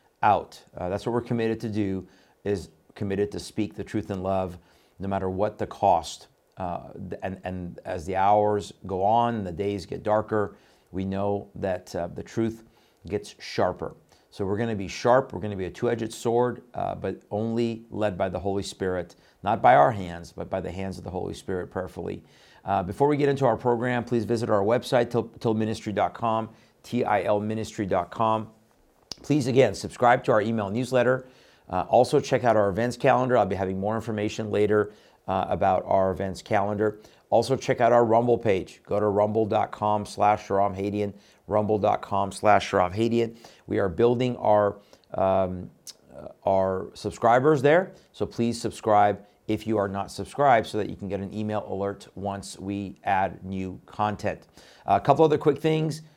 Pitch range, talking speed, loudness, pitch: 100-115 Hz, 175 wpm, -26 LUFS, 105 Hz